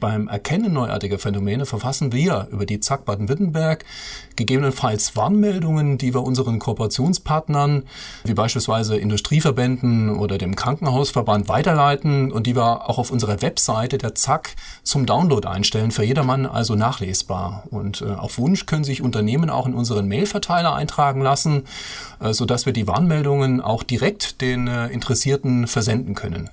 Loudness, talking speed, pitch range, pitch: -20 LUFS, 135 wpm, 105-140 Hz, 125 Hz